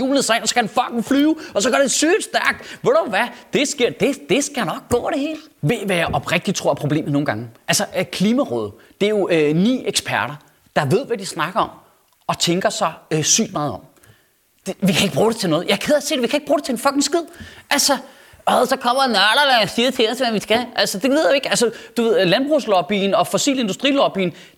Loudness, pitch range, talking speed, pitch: -18 LUFS, 185-275 Hz, 250 wpm, 230 Hz